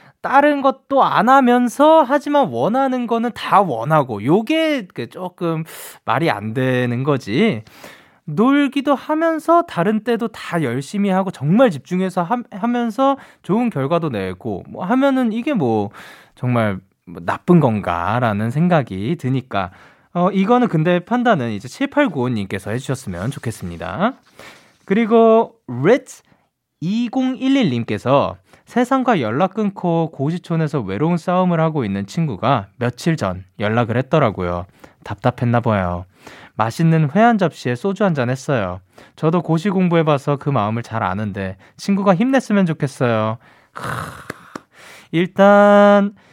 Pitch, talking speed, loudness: 165 Hz, 265 characters per minute, -18 LUFS